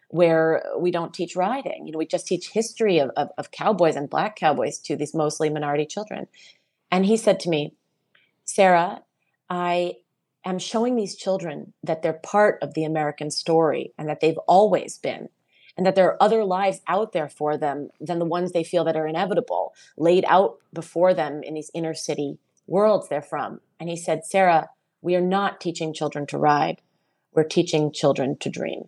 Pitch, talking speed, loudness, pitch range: 170 Hz, 190 wpm, -23 LUFS, 155-185 Hz